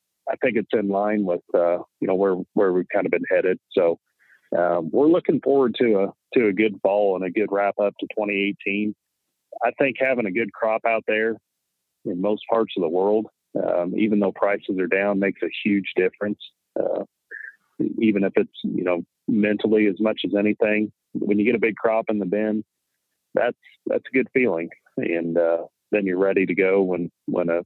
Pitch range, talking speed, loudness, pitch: 90-110 Hz, 200 wpm, -22 LUFS, 100 Hz